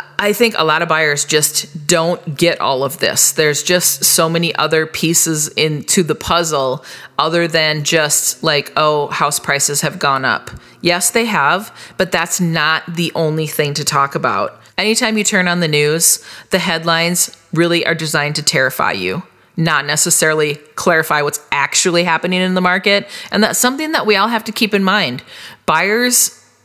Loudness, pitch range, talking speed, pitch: -14 LUFS, 150-185 Hz, 175 wpm, 165 Hz